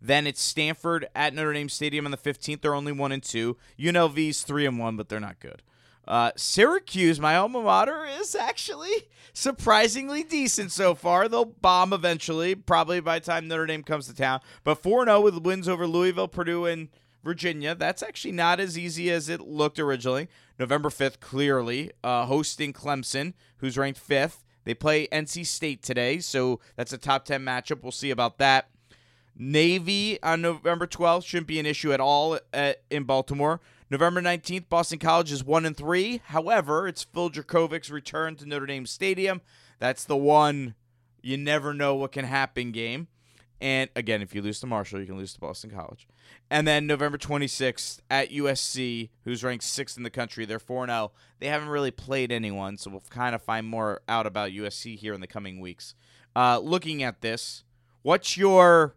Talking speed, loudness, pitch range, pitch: 180 wpm, -26 LUFS, 125-170 Hz, 145 Hz